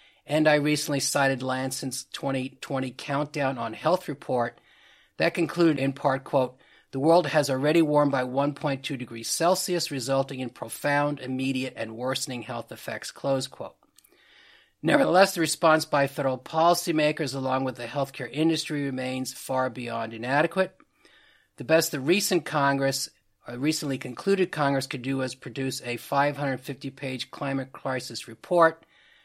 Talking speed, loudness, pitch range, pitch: 135 wpm, -26 LUFS, 130-160 Hz, 140 Hz